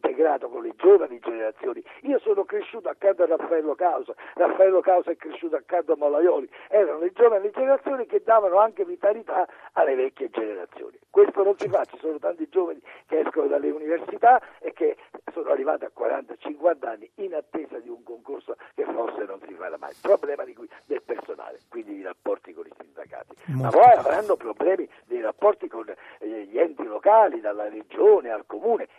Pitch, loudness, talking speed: 365 Hz, -23 LUFS, 175 wpm